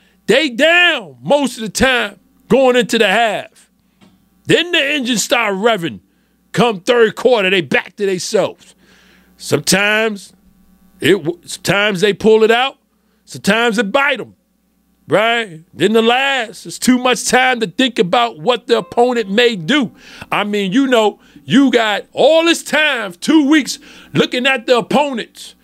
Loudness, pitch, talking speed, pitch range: -14 LUFS, 230 Hz, 150 wpm, 200-255 Hz